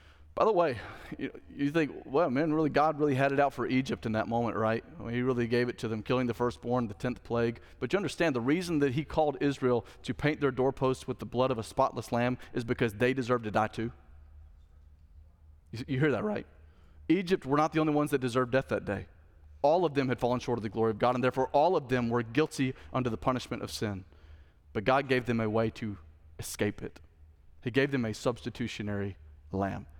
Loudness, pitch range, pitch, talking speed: -30 LUFS, 100-130 Hz, 120 Hz, 225 wpm